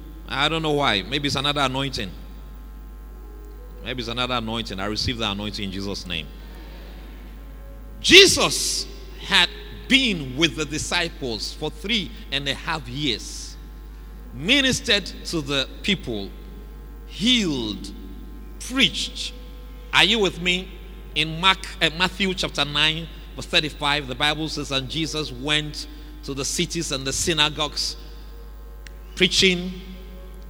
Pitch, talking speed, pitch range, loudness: 150 Hz, 120 wpm, 125-175 Hz, -21 LUFS